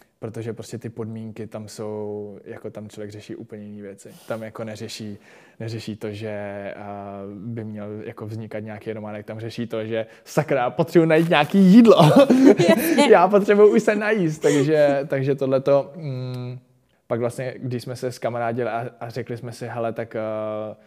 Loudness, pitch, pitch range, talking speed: -19 LUFS, 115 Hz, 110-135 Hz, 165 wpm